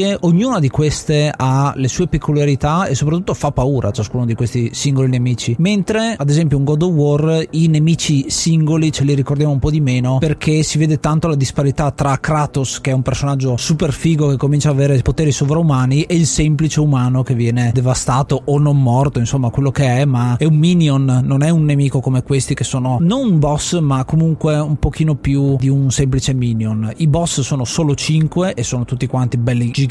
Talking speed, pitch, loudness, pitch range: 205 wpm, 140 Hz, -15 LUFS, 130-155 Hz